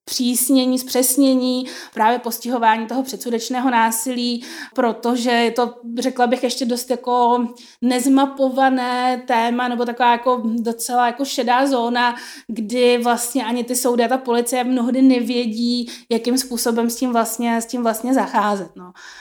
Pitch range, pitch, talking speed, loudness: 235-255 Hz, 245 Hz, 135 wpm, -18 LUFS